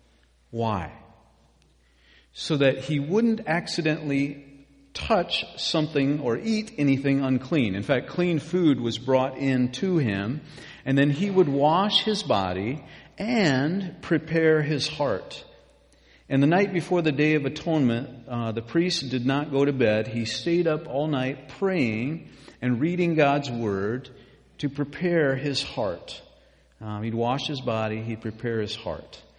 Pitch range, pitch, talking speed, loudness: 115-165 Hz, 140 Hz, 145 wpm, -25 LUFS